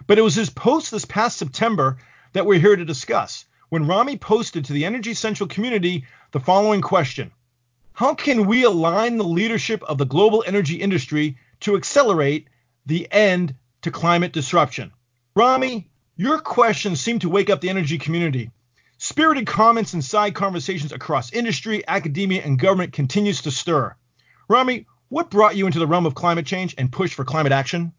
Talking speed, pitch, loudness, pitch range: 170 wpm, 180 Hz, -20 LUFS, 150-210 Hz